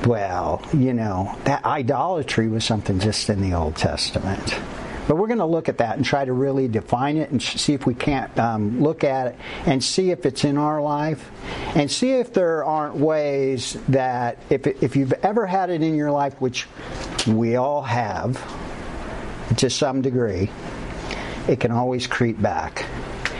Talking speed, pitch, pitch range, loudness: 175 wpm, 135 Hz, 115-150 Hz, -22 LUFS